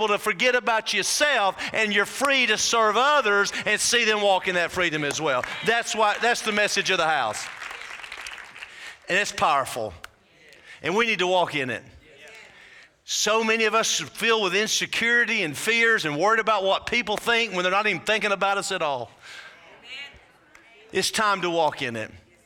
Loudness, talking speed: -22 LUFS, 180 wpm